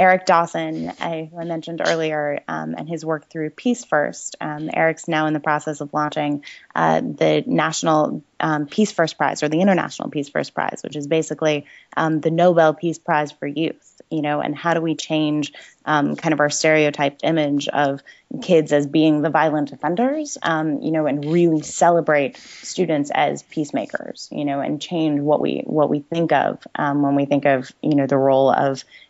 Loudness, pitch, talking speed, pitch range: -20 LUFS, 155 Hz, 195 wpm, 145-160 Hz